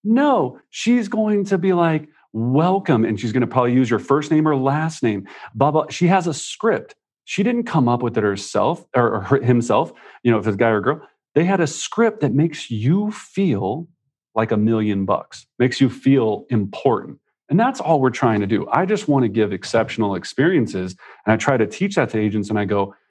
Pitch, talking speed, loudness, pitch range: 130 Hz, 220 wpm, -19 LUFS, 110-165 Hz